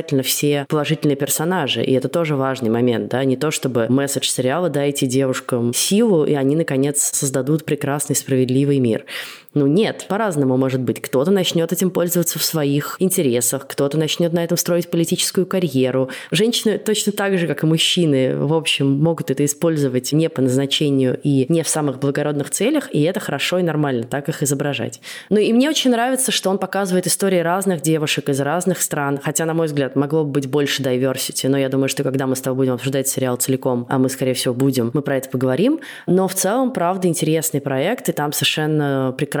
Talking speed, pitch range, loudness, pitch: 190 wpm, 135-170 Hz, -18 LUFS, 145 Hz